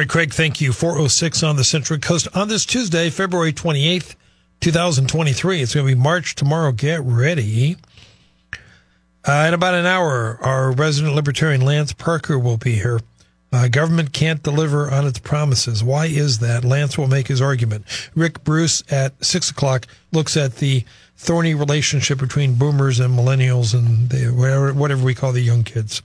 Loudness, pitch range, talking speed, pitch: -18 LUFS, 125-160 Hz, 170 wpm, 140 Hz